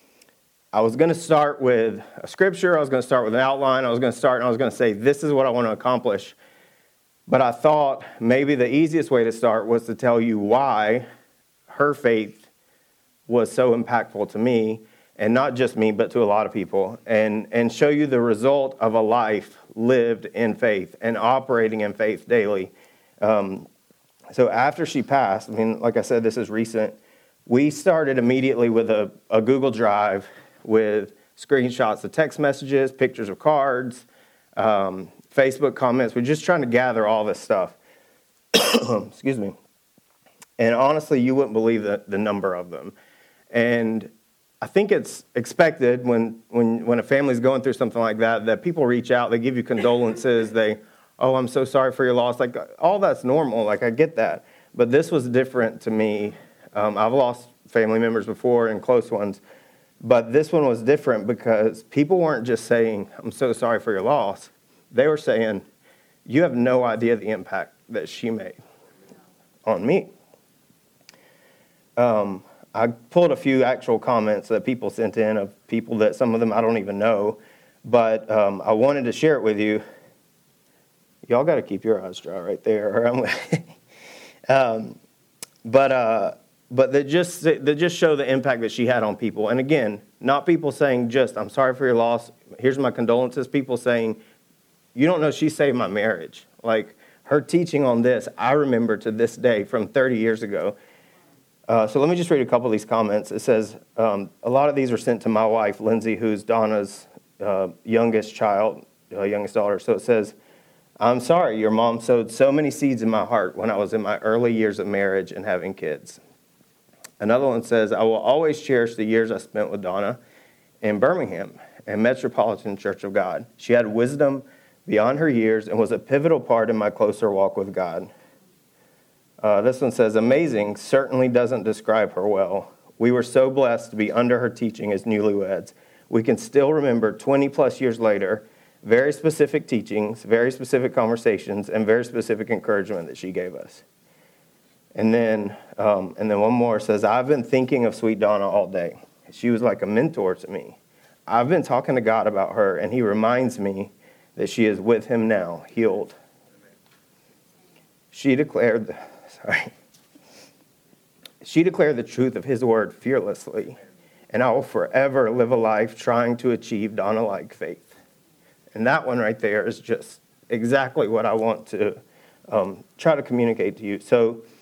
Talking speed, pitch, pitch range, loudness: 180 wpm, 115 Hz, 110-130 Hz, -21 LUFS